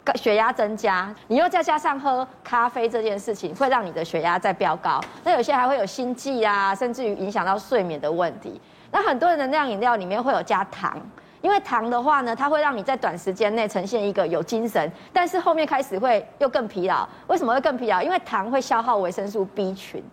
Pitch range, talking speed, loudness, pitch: 200-275 Hz, 330 characters per minute, -23 LUFS, 235 Hz